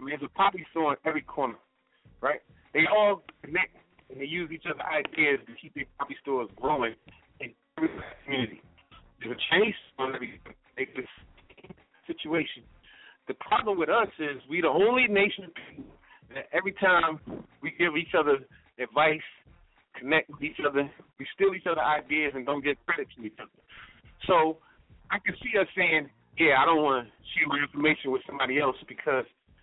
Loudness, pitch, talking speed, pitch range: -27 LUFS, 155 Hz, 170 wpm, 140-185 Hz